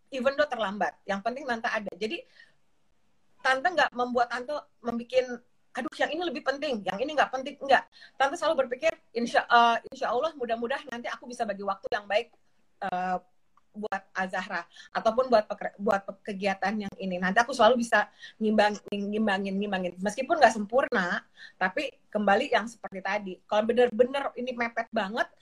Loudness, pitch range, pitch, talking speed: -28 LUFS, 200-260 Hz, 235 Hz, 160 wpm